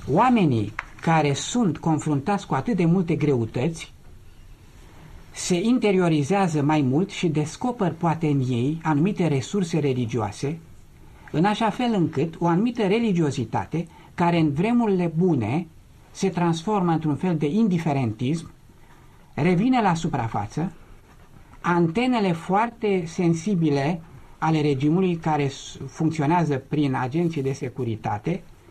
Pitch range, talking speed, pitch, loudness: 140-180 Hz, 110 wpm, 160 Hz, -23 LUFS